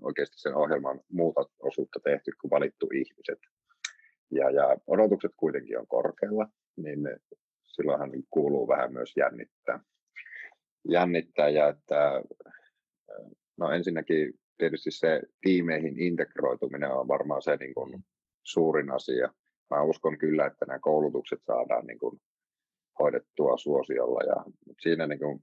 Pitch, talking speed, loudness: 390 Hz, 120 wpm, -29 LUFS